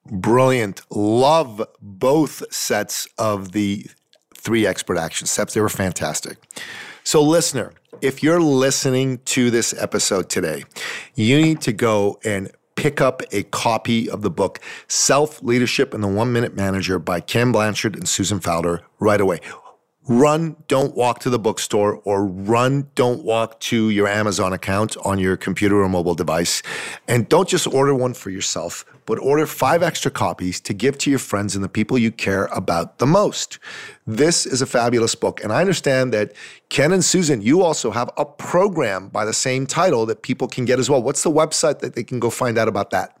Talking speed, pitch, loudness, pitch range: 185 wpm, 120 Hz, -19 LUFS, 100-135 Hz